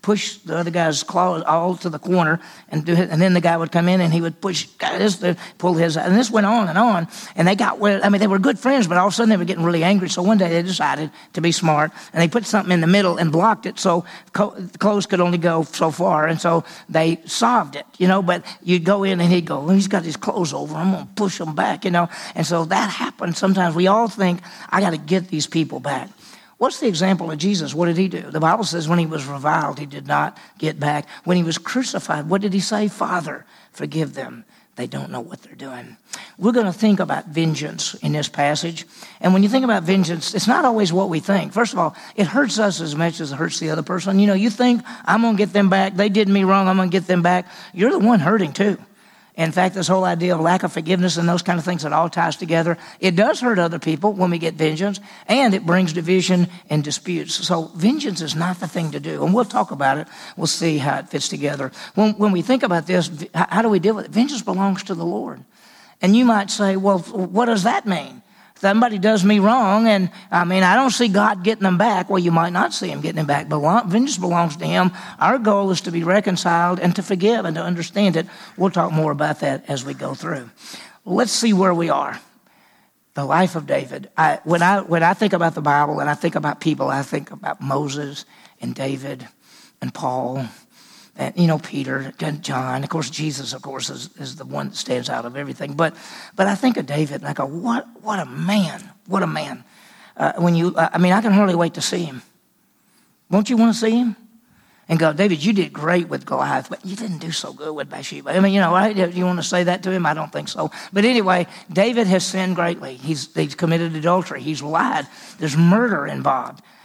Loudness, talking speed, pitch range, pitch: -19 LUFS, 245 wpm, 165-205 Hz, 180 Hz